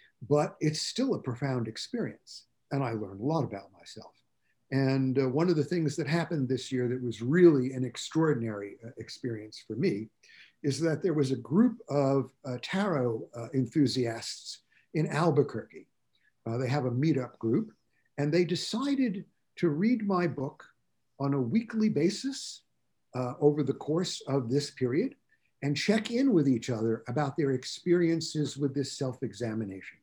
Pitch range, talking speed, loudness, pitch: 125-165 Hz, 160 wpm, -30 LUFS, 140 Hz